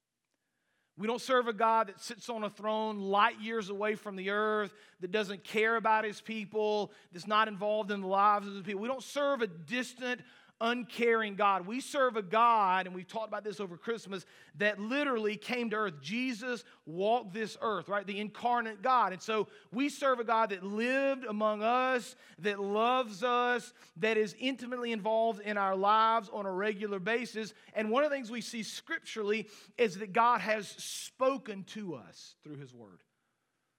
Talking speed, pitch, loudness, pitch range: 185 wpm, 215 Hz, -32 LUFS, 205-235 Hz